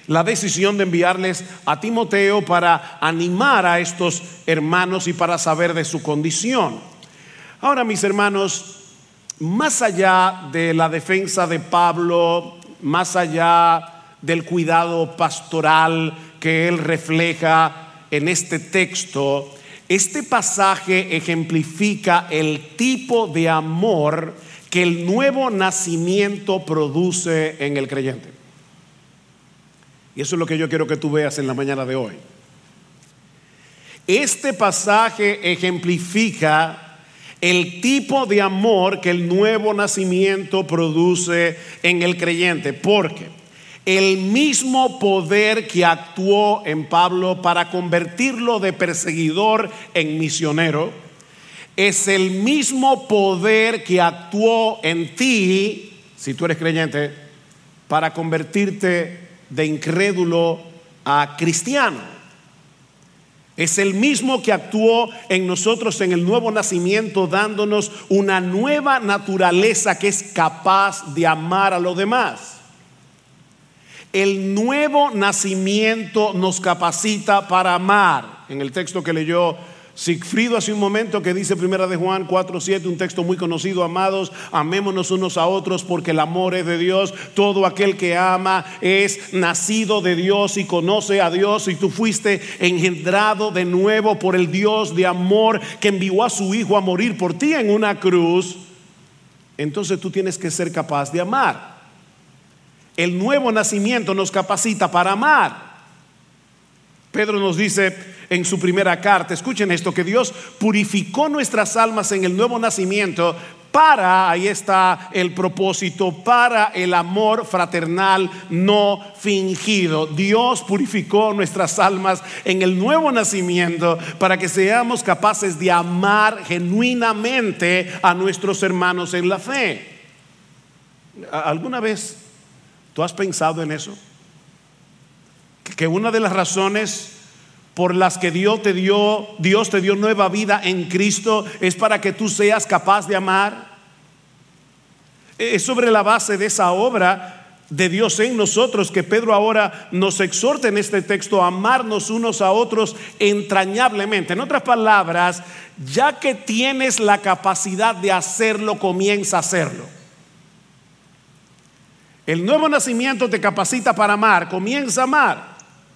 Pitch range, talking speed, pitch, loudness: 170-205 Hz, 130 wpm, 185 Hz, -18 LUFS